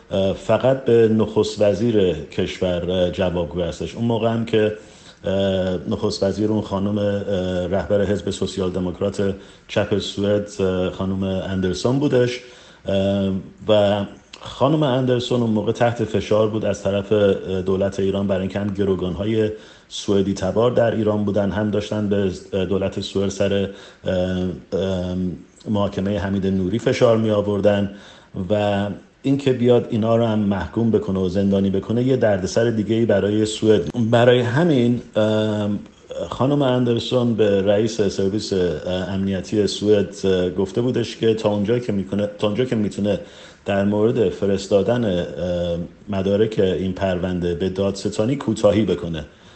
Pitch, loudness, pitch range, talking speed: 100 Hz, -20 LUFS, 95-110 Hz, 125 wpm